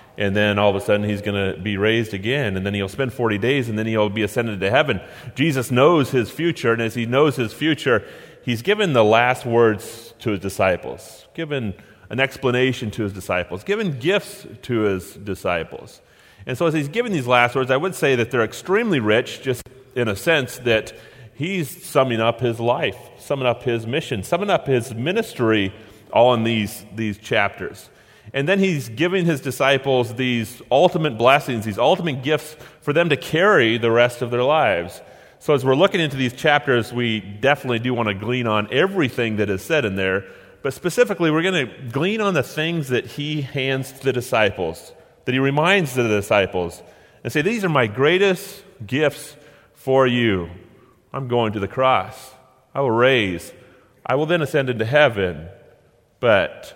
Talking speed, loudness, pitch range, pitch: 185 wpm, -20 LUFS, 110-145 Hz, 125 Hz